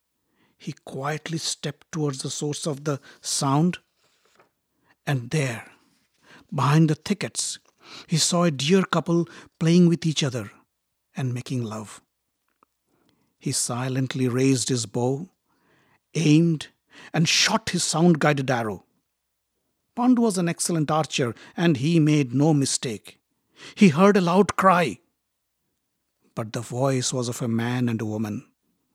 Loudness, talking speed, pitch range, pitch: -23 LUFS, 130 wpm, 130-170 Hz, 150 Hz